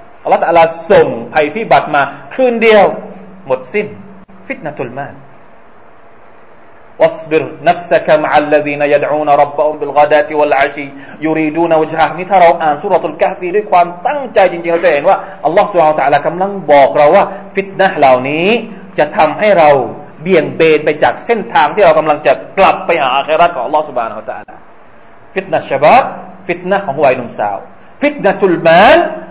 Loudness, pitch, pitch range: -11 LUFS, 175 Hz, 150-205 Hz